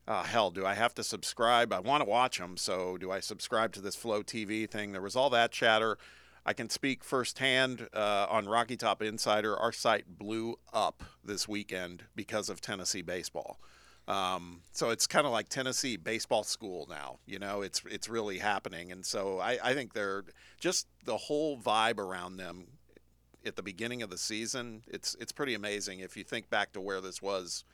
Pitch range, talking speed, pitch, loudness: 95-115 Hz, 195 wpm, 105 Hz, -33 LUFS